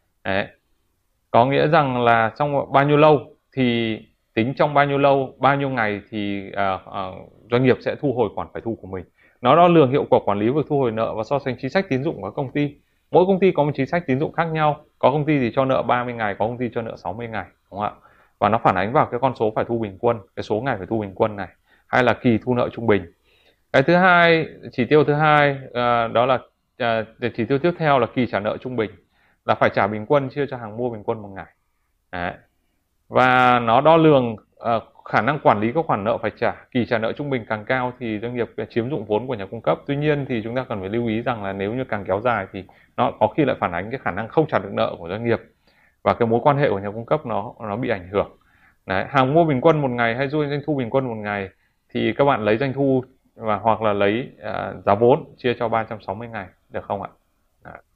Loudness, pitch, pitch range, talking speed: -21 LUFS, 120 Hz, 110-140 Hz, 265 wpm